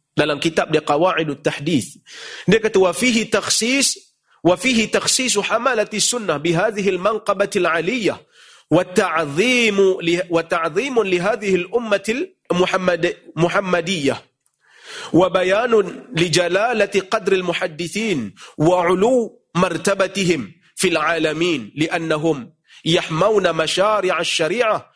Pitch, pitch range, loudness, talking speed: 185 Hz, 170-210 Hz, -18 LUFS, 75 wpm